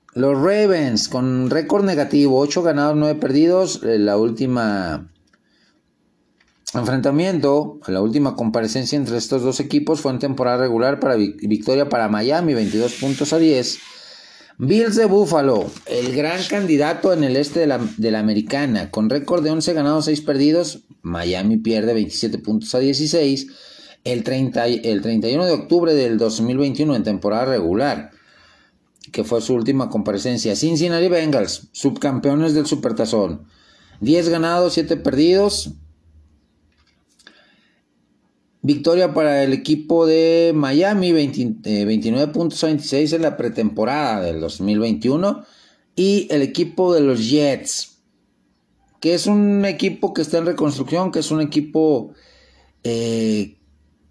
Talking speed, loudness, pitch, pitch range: 130 wpm, -18 LUFS, 140 Hz, 115-160 Hz